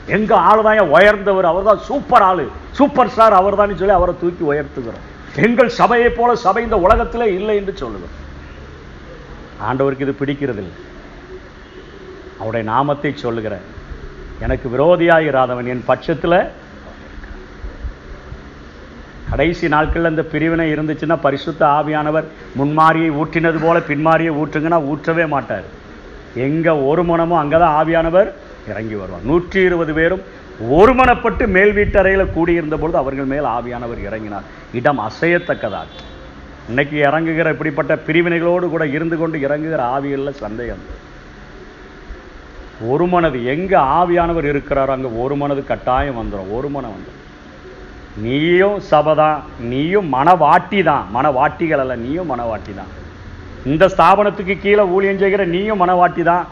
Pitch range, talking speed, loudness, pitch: 110-175 Hz, 115 wpm, -15 LUFS, 150 Hz